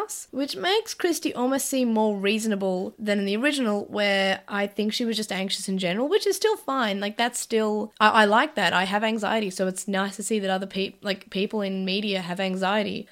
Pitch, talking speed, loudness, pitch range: 210 Hz, 220 wpm, -24 LUFS, 195-235 Hz